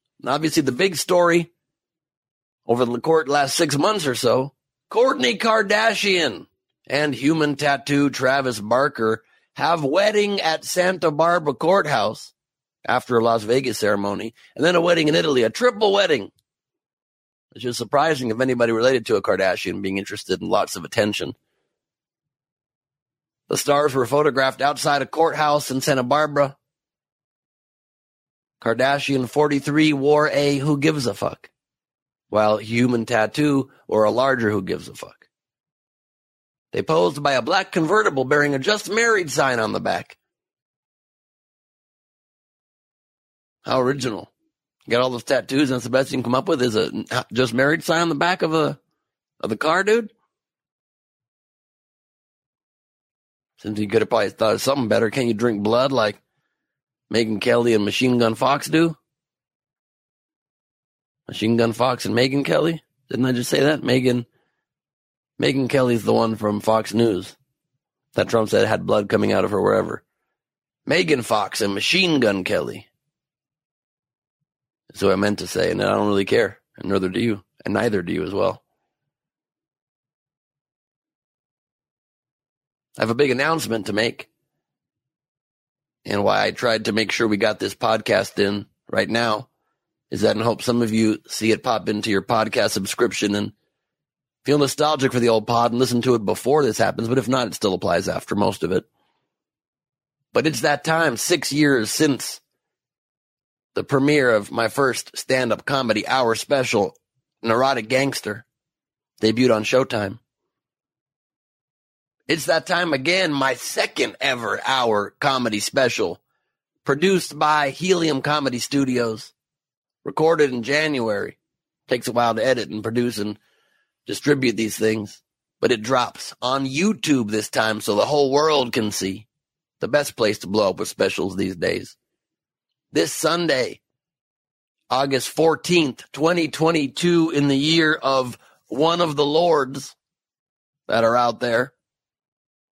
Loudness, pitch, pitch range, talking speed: -20 LUFS, 135 Hz, 115-150 Hz, 150 wpm